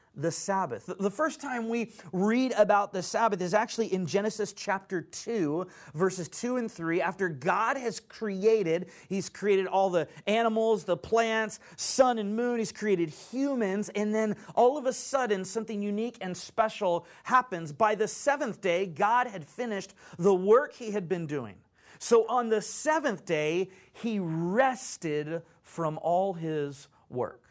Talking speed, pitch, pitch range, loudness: 155 wpm, 200 Hz, 175-225 Hz, -29 LUFS